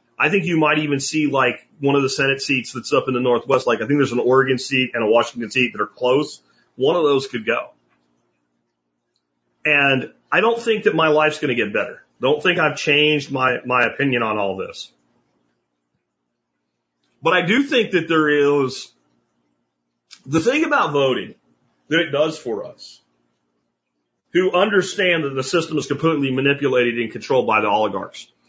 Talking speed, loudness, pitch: 180 wpm, -19 LUFS, 135 Hz